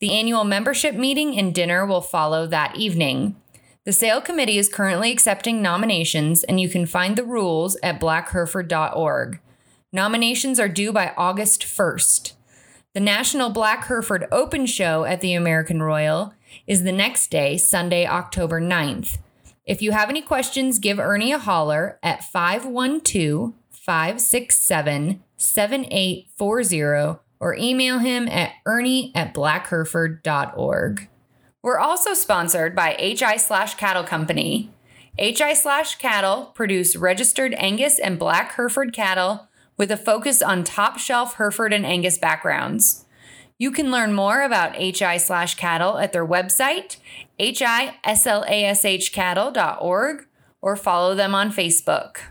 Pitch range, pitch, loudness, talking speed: 175-240 Hz, 200 Hz, -20 LUFS, 130 wpm